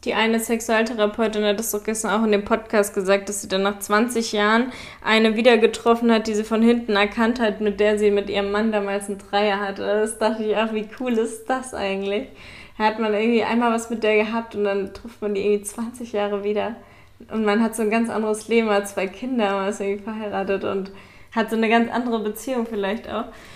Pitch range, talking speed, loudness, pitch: 205-225 Hz, 225 wpm, -22 LUFS, 215 Hz